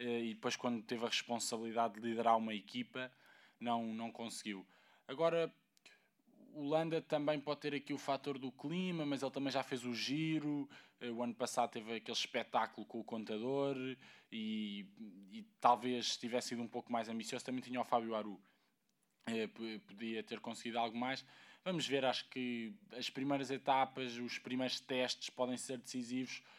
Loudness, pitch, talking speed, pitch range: -40 LUFS, 125 Hz, 160 wpm, 115-145 Hz